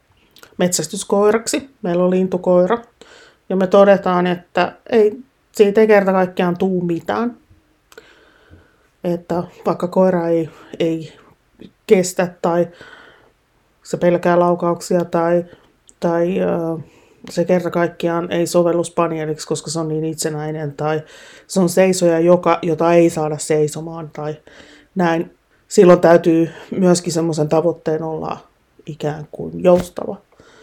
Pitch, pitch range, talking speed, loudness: 175 Hz, 165-190 Hz, 115 wpm, -17 LUFS